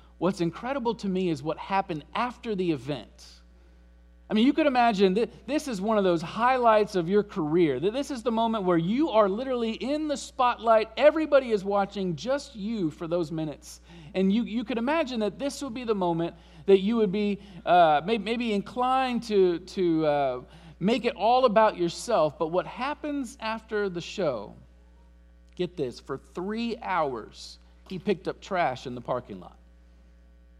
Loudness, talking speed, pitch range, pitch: -26 LUFS, 175 wpm, 165-235 Hz, 200 Hz